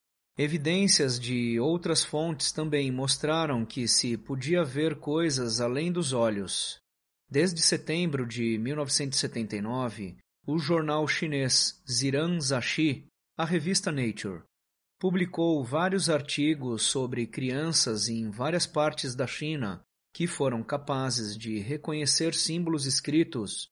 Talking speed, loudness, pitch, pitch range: 110 wpm, -28 LUFS, 145 Hz, 120-160 Hz